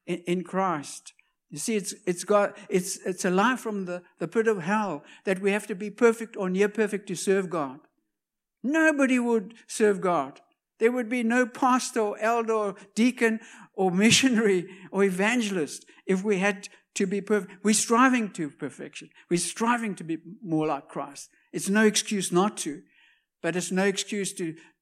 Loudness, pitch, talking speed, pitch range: -26 LUFS, 205 Hz, 175 wpm, 185-225 Hz